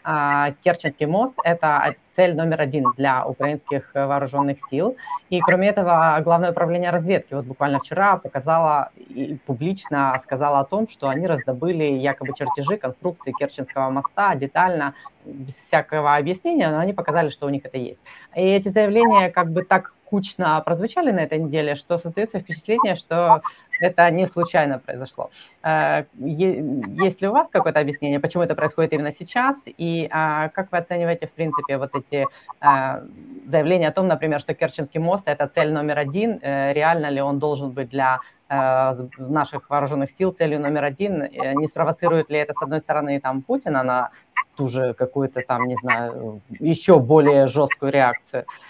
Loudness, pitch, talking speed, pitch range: -21 LUFS, 155 Hz, 155 wpm, 140-180 Hz